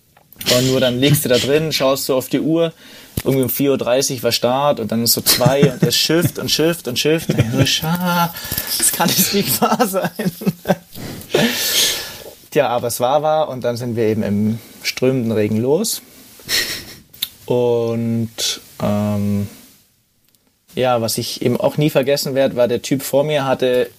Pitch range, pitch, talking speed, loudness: 120-160 Hz, 135 Hz, 175 wpm, -17 LUFS